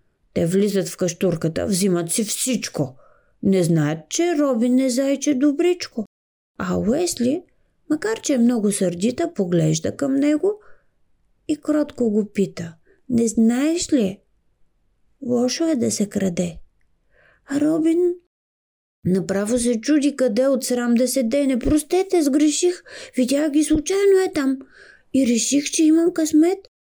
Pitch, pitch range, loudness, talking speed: 265 Hz, 210-310 Hz, -20 LUFS, 130 wpm